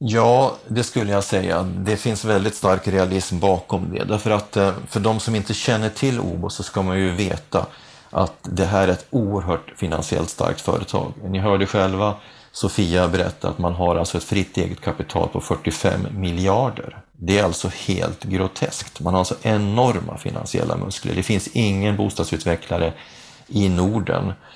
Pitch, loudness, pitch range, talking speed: 100 Hz, -21 LUFS, 90-110 Hz, 165 wpm